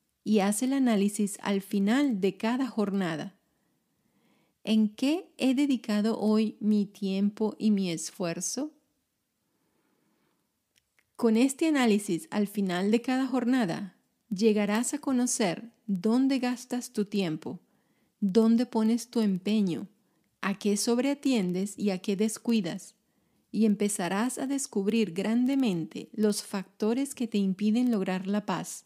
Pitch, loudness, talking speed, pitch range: 215 Hz, -28 LUFS, 120 wpm, 200-245 Hz